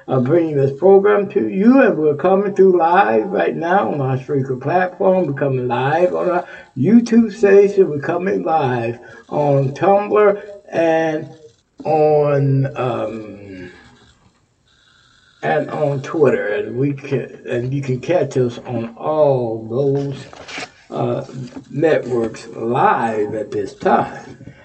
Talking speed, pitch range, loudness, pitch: 125 wpm, 125-180 Hz, -17 LUFS, 145 Hz